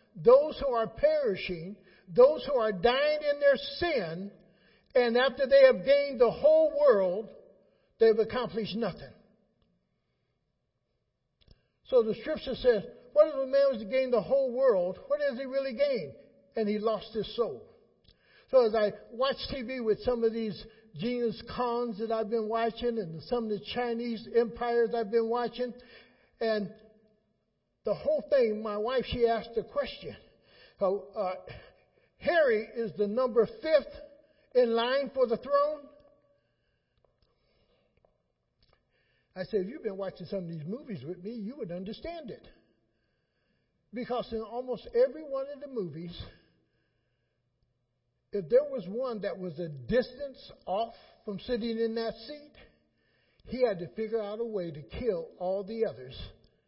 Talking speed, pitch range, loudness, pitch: 150 wpm, 210-270 Hz, -29 LUFS, 235 Hz